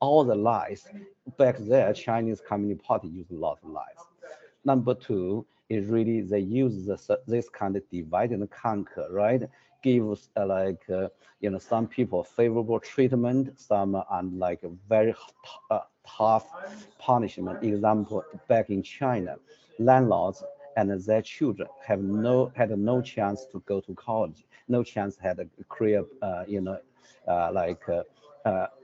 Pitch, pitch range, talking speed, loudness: 110 Hz, 100-120 Hz, 155 wpm, -27 LUFS